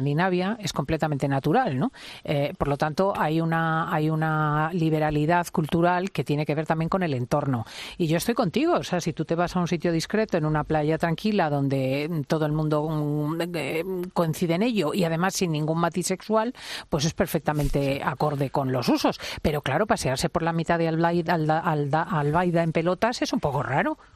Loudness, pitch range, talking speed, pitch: -25 LUFS, 150-180 Hz, 190 wpm, 165 Hz